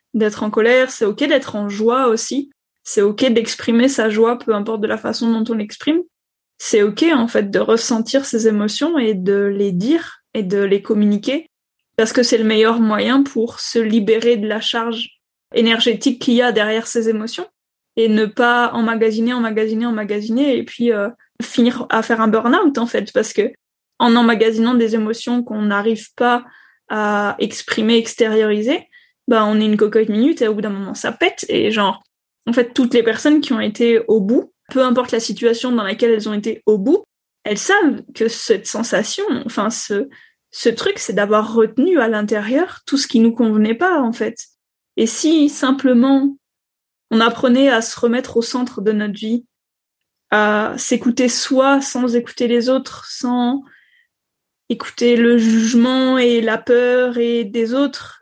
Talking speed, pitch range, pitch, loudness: 180 wpm, 220-255 Hz, 235 Hz, -16 LUFS